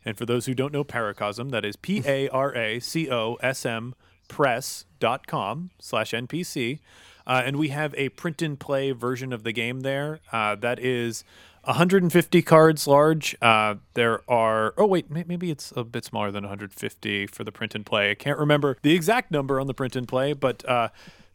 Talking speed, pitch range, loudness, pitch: 200 wpm, 115-150 Hz, -24 LUFS, 130 Hz